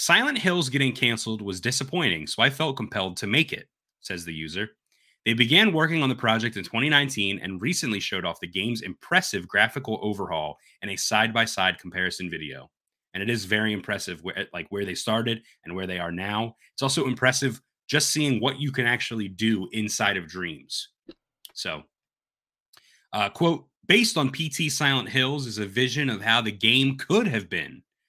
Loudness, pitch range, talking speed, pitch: -24 LUFS, 100-140 Hz, 185 wpm, 115 Hz